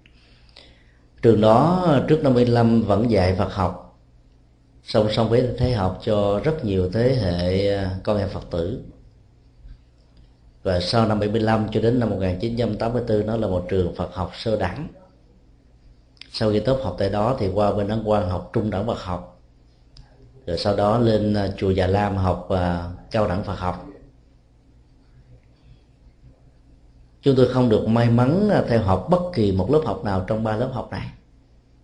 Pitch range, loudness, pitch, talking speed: 85-115 Hz, -21 LUFS, 100 Hz, 165 wpm